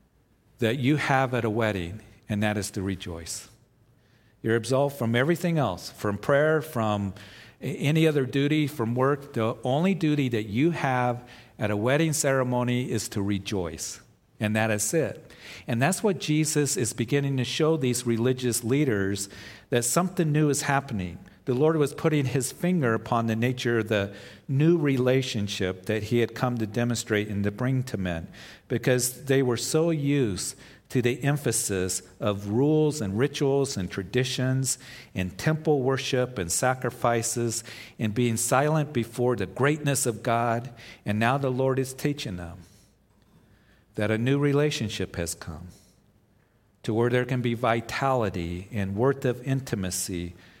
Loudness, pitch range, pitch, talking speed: -26 LUFS, 105-135 Hz, 120 Hz, 155 wpm